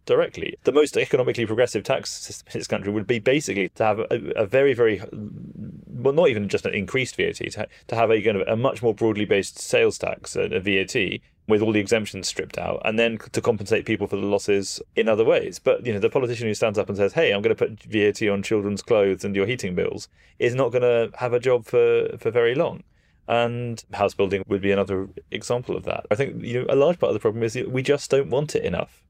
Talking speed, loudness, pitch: 235 wpm, -23 LUFS, 115 Hz